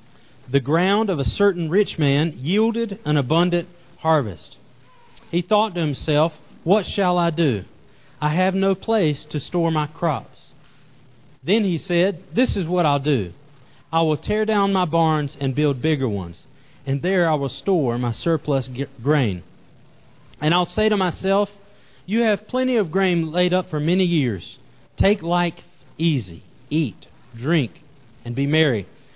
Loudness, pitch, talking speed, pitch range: -21 LUFS, 155 Hz, 160 wpm, 135-185 Hz